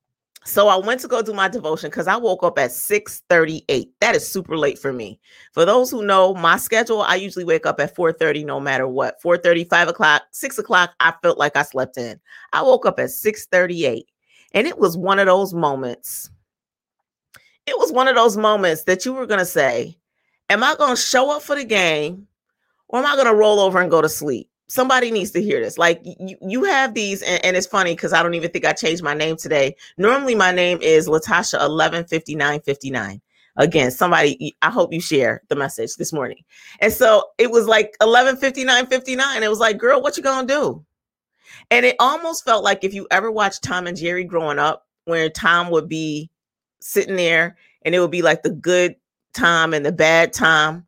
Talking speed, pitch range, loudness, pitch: 210 wpm, 160-230 Hz, -18 LUFS, 180 Hz